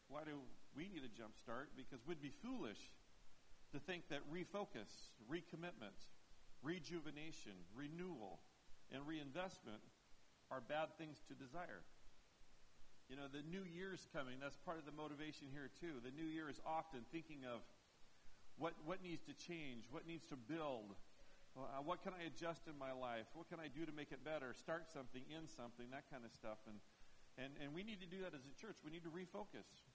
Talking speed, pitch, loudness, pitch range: 185 wpm, 150 Hz, -53 LUFS, 130-165 Hz